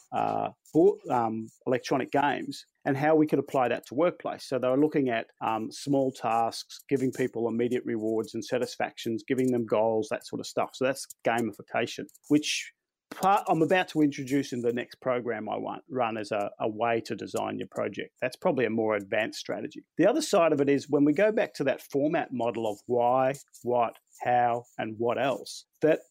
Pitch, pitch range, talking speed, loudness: 125 Hz, 115-140 Hz, 195 wpm, -28 LUFS